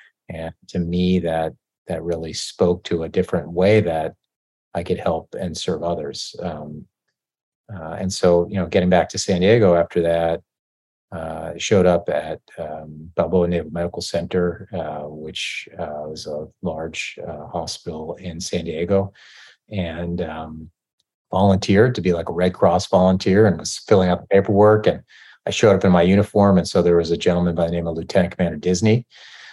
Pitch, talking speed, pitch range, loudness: 85 Hz, 175 wpm, 80-95 Hz, -20 LUFS